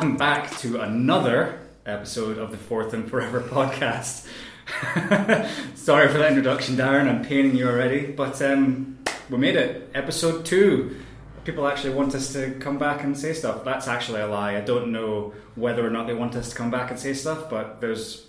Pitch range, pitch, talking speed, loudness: 120-140 Hz, 130 Hz, 185 wpm, -24 LUFS